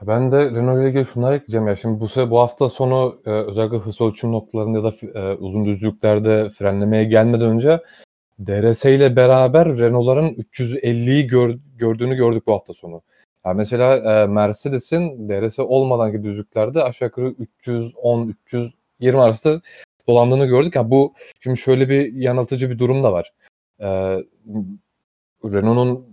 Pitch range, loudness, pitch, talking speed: 110-130 Hz, -18 LUFS, 120 Hz, 140 wpm